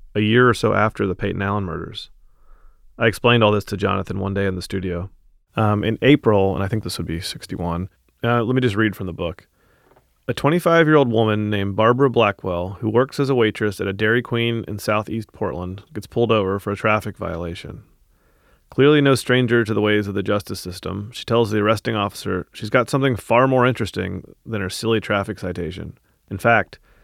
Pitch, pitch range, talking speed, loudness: 105 Hz, 95-115 Hz, 205 wpm, -20 LUFS